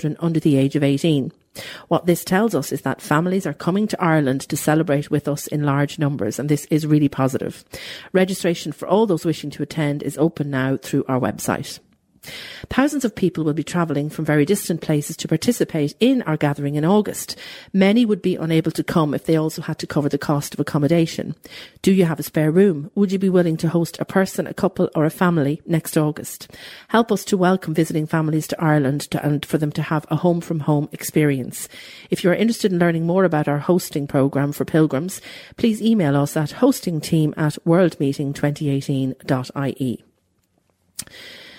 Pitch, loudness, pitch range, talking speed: 155 Hz, -20 LUFS, 145-175 Hz, 195 wpm